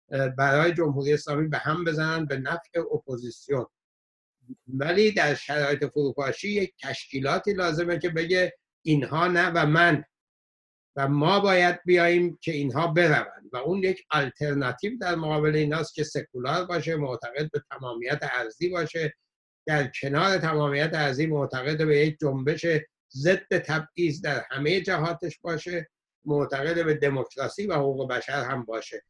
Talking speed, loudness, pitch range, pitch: 135 wpm, -26 LUFS, 140-170 Hz, 155 Hz